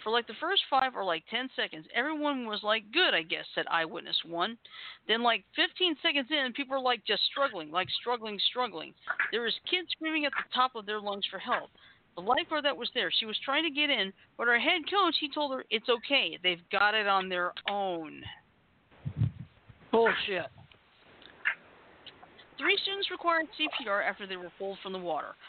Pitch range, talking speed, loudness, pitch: 200-295 Hz, 190 wpm, -30 LUFS, 240 Hz